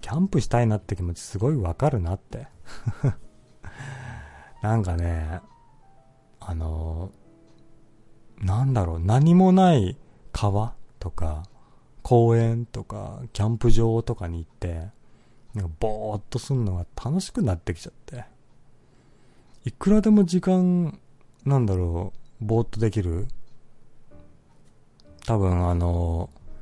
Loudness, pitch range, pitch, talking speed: -24 LUFS, 95-130 Hz, 115 Hz, 225 characters per minute